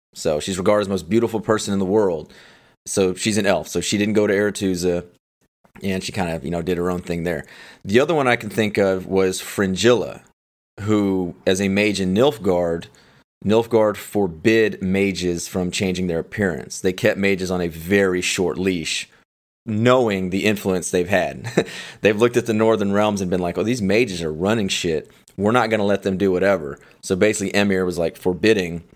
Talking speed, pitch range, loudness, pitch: 200 wpm, 90-105 Hz, -20 LUFS, 95 Hz